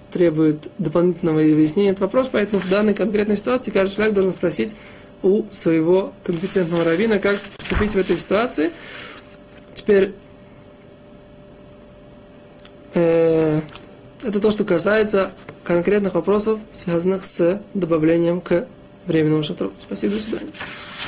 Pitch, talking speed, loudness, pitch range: 190 Hz, 115 wpm, -19 LUFS, 165-205 Hz